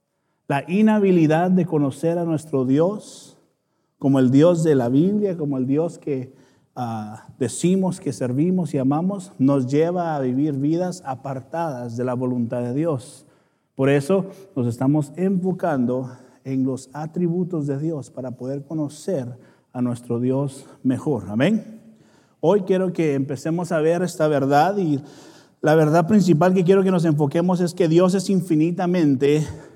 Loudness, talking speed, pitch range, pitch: -21 LUFS, 150 wpm, 135-175 Hz, 150 Hz